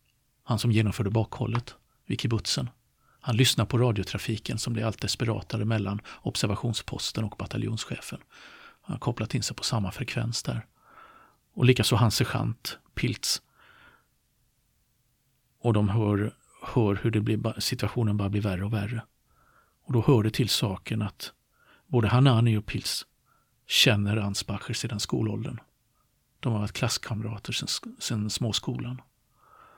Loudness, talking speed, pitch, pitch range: -27 LUFS, 135 wpm, 115 Hz, 105-125 Hz